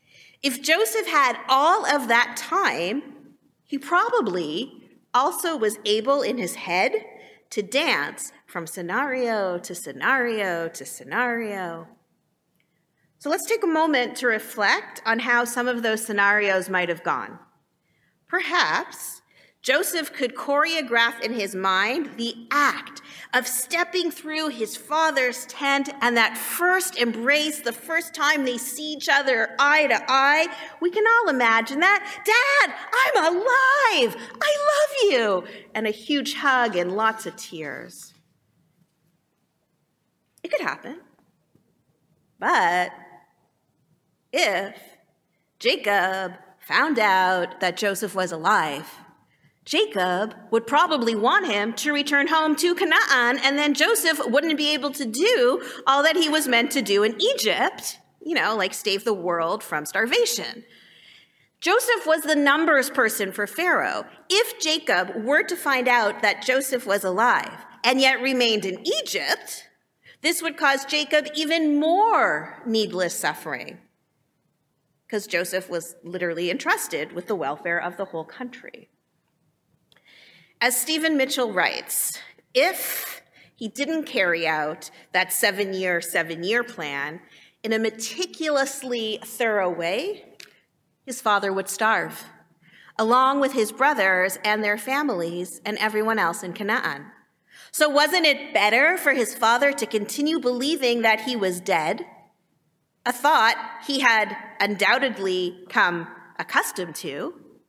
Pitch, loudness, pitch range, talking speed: 245 Hz, -22 LUFS, 205-300 Hz, 130 wpm